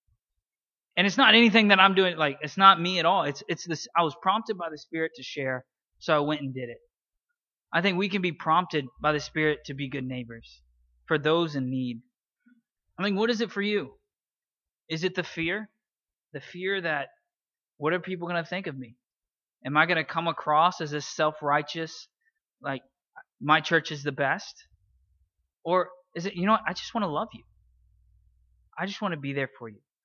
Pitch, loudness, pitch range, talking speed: 160 Hz, -26 LUFS, 140-190 Hz, 200 wpm